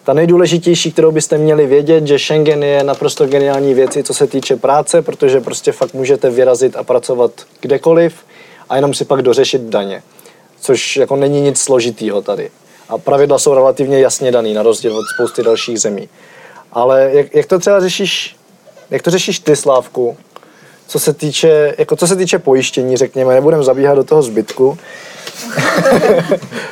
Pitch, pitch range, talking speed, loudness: 155 Hz, 135-200 Hz, 165 wpm, -12 LUFS